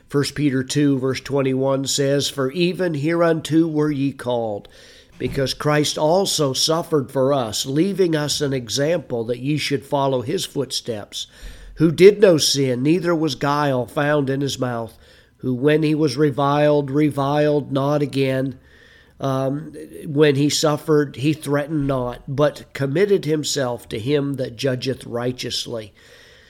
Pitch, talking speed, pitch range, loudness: 140 Hz, 140 wpm, 130-150 Hz, -20 LUFS